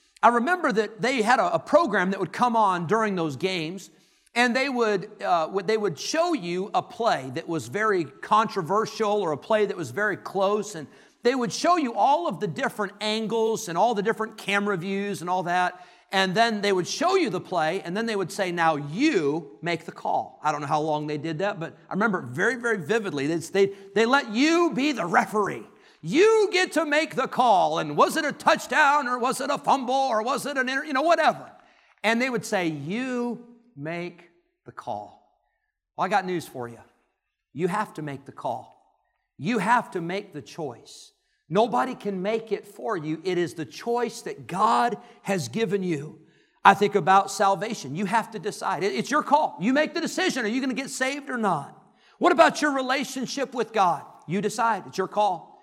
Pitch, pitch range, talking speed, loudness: 210 Hz, 185-255 Hz, 210 wpm, -24 LUFS